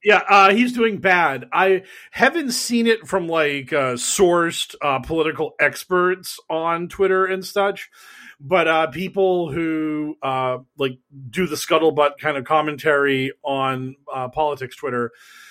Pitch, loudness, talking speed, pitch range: 165 Hz, -19 LUFS, 140 wpm, 145-195 Hz